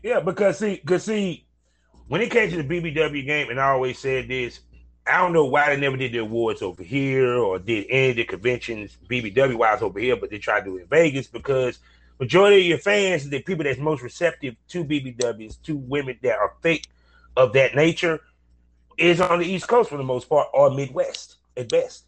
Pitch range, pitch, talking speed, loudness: 120-170 Hz, 135 Hz, 215 wpm, -22 LUFS